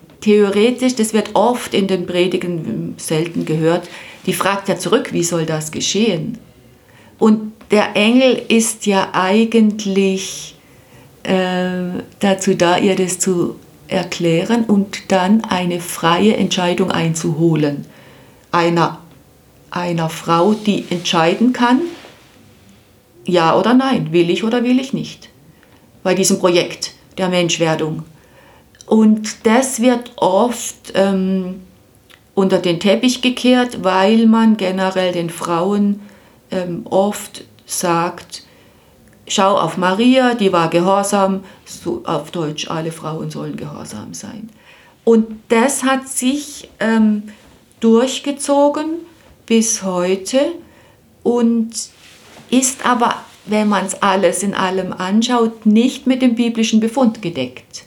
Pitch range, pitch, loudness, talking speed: 175-225 Hz, 190 Hz, -16 LUFS, 115 wpm